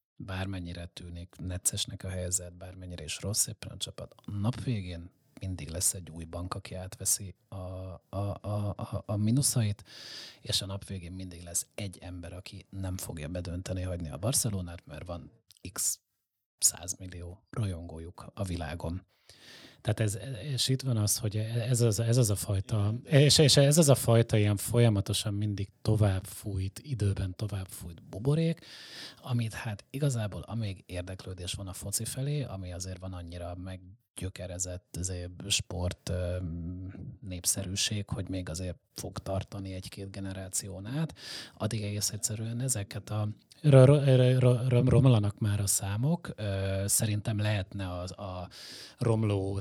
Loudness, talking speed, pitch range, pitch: -30 LUFS, 150 wpm, 90-115 Hz, 100 Hz